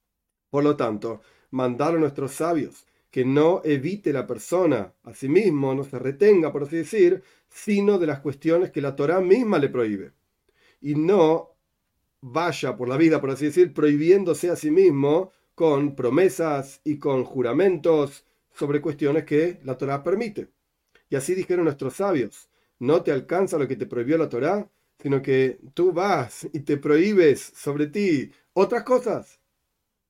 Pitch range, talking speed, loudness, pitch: 135-170 Hz, 155 wpm, -23 LUFS, 150 Hz